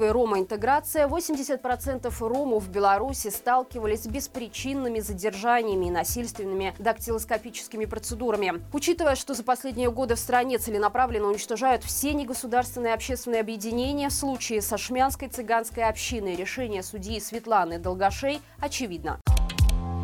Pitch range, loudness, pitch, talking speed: 215-255 Hz, -27 LUFS, 230 Hz, 115 wpm